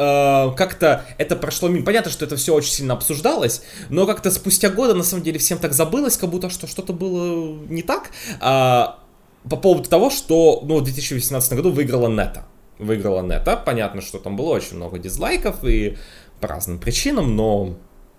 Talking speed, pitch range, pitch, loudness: 170 wpm, 120-180 Hz, 150 Hz, -19 LUFS